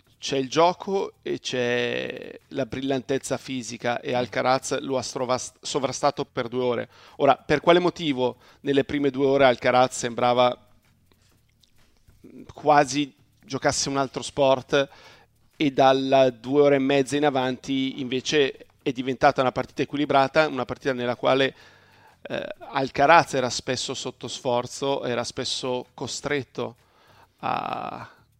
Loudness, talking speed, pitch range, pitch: -24 LUFS, 125 wpm, 125-140 Hz, 130 Hz